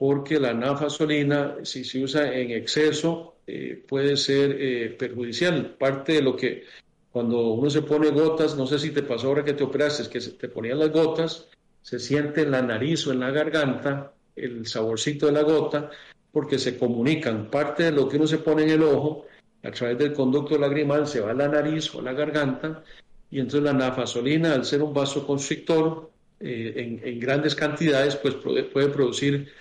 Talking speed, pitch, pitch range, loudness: 190 wpm, 145 Hz, 135-150 Hz, -24 LUFS